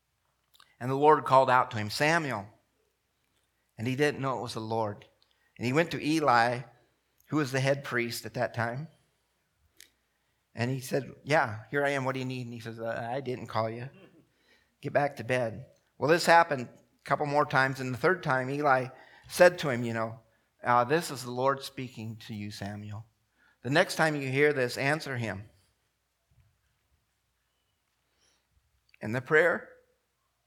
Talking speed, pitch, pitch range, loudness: 175 wpm, 130 Hz, 115-145 Hz, -28 LUFS